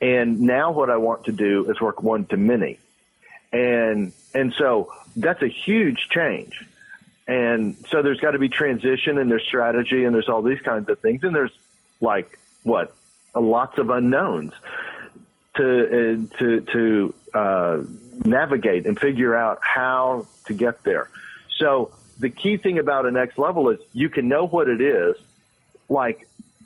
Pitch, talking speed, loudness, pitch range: 125 Hz, 165 wpm, -21 LUFS, 115-140 Hz